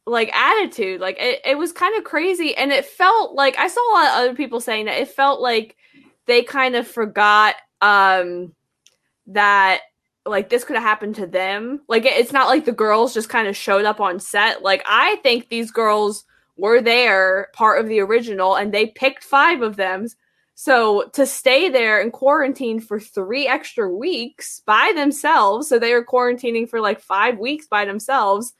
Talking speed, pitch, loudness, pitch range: 190 wpm, 230 Hz, -17 LUFS, 205-270 Hz